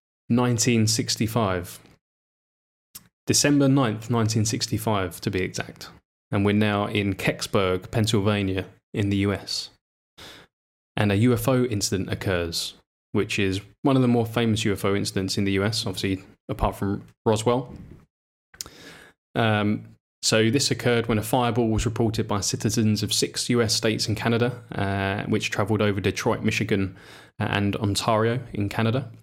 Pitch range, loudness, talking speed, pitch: 100-115 Hz, -24 LUFS, 130 wpm, 110 Hz